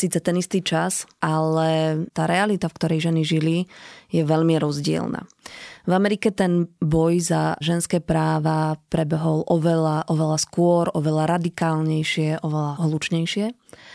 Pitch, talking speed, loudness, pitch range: 165 Hz, 125 wpm, -22 LUFS, 160-175 Hz